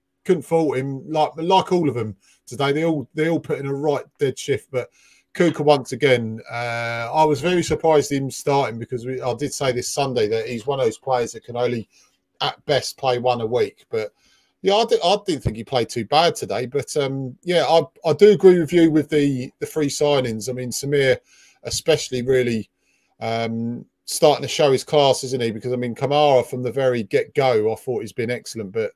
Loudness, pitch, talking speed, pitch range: -20 LUFS, 140 Hz, 220 wpm, 125-160 Hz